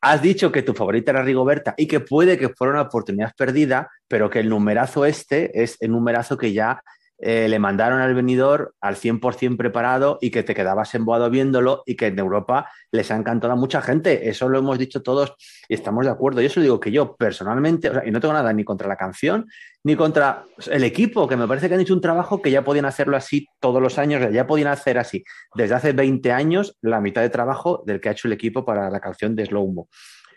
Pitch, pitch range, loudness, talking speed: 130 Hz, 115-145 Hz, -20 LUFS, 235 wpm